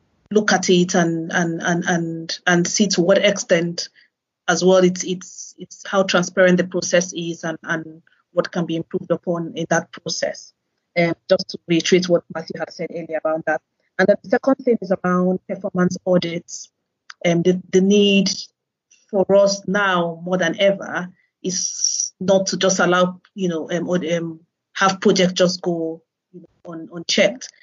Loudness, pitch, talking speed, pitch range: -19 LUFS, 180 Hz, 175 wpm, 170-190 Hz